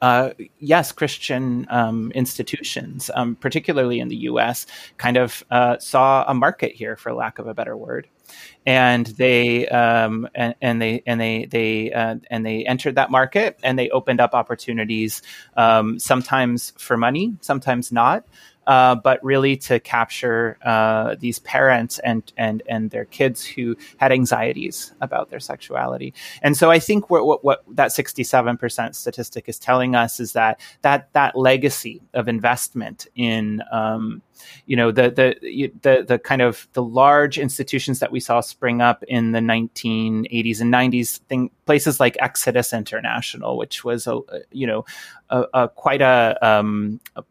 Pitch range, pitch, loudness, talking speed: 115-130 Hz, 120 Hz, -19 LUFS, 165 wpm